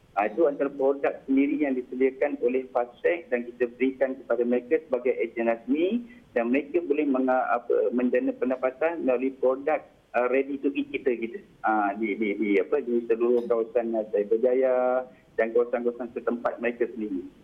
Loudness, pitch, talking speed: -26 LUFS, 135 Hz, 155 wpm